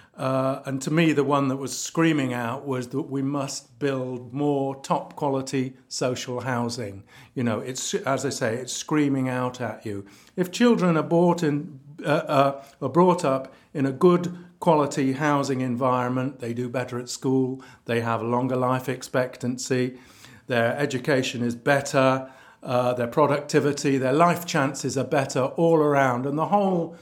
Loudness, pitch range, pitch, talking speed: -24 LUFS, 125-145 Hz, 135 Hz, 165 wpm